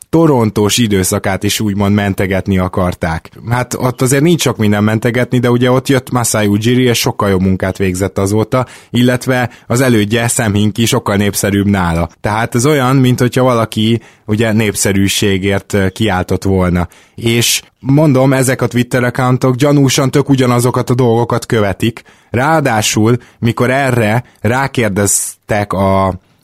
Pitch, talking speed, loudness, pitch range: 115 Hz, 135 wpm, -12 LUFS, 100-125 Hz